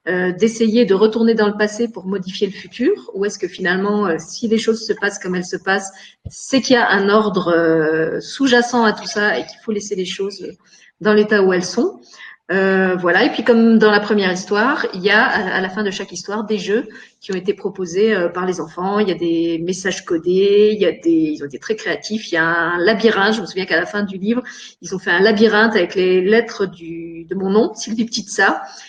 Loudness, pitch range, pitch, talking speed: -17 LUFS, 185-220 Hz, 200 Hz, 235 wpm